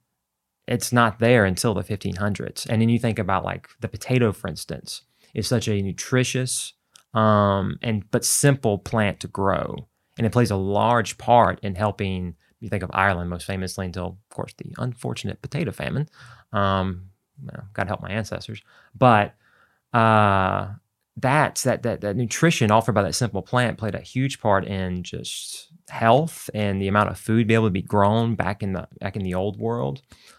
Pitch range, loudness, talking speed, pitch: 95-120 Hz, -23 LUFS, 185 wpm, 105 Hz